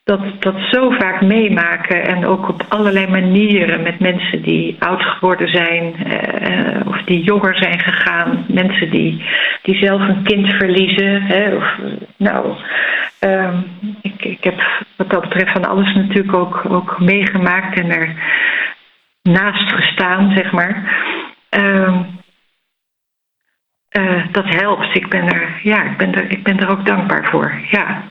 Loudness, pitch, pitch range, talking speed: -14 LUFS, 190 Hz, 180-200 Hz, 145 wpm